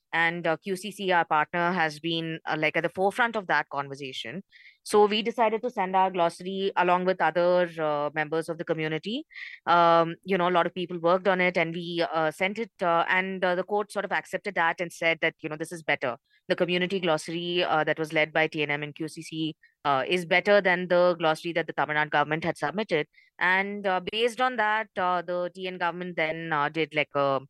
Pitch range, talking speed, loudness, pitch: 160-185 Hz, 220 wpm, -26 LUFS, 170 Hz